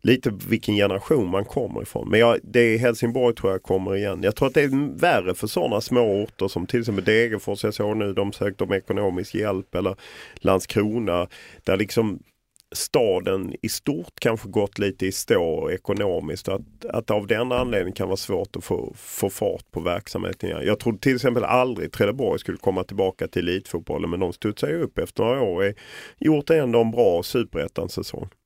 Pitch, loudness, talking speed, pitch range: 110 Hz, -23 LUFS, 185 wpm, 100-125 Hz